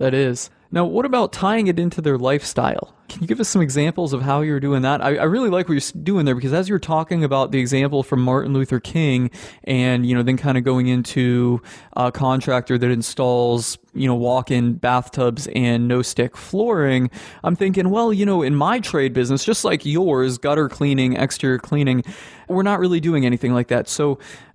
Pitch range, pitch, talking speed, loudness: 125-170 Hz, 135 Hz, 220 wpm, -19 LUFS